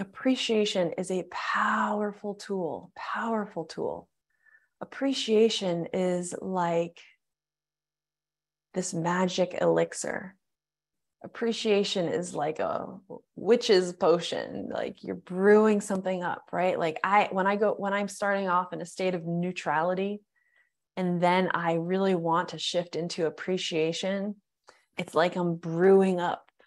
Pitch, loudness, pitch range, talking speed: 185 Hz, -28 LUFS, 170-205 Hz, 120 wpm